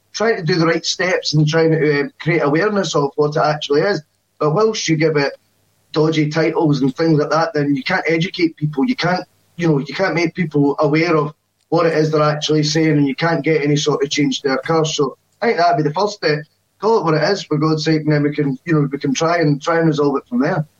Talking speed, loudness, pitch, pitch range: 265 wpm, -17 LUFS, 155 Hz, 145-165 Hz